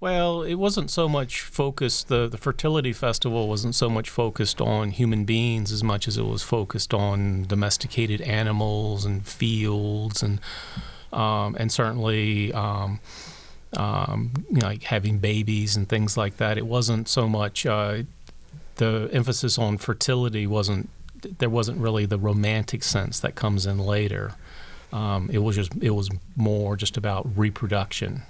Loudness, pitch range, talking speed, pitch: -25 LUFS, 105-120 Hz, 155 wpm, 110 Hz